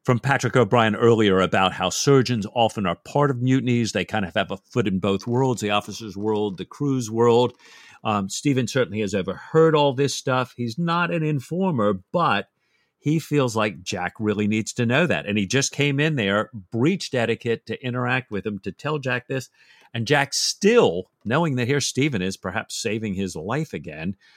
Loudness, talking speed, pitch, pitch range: -22 LUFS, 190 wpm, 120 Hz, 105-140 Hz